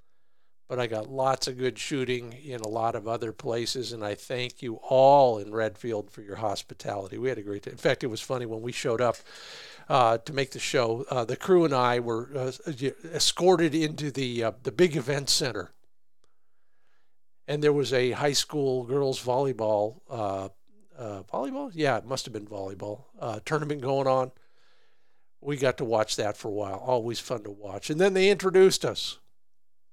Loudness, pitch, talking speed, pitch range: -27 LUFS, 125 Hz, 190 wpm, 115-140 Hz